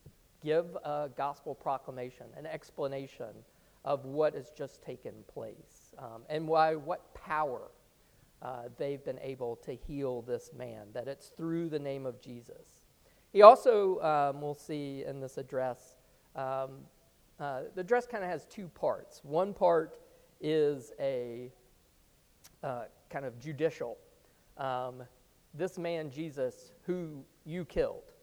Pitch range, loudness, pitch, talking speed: 130-165 Hz, -33 LUFS, 145 Hz, 135 wpm